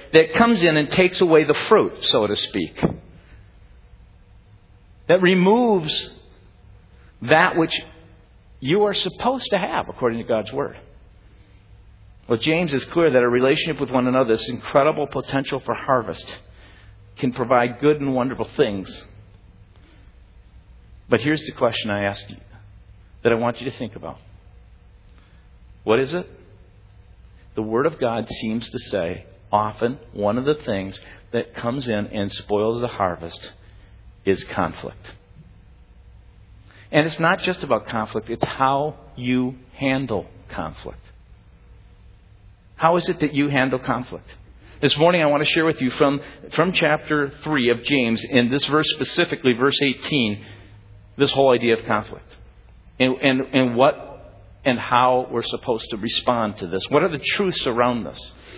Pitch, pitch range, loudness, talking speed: 120 Hz, 100-145 Hz, -20 LUFS, 150 wpm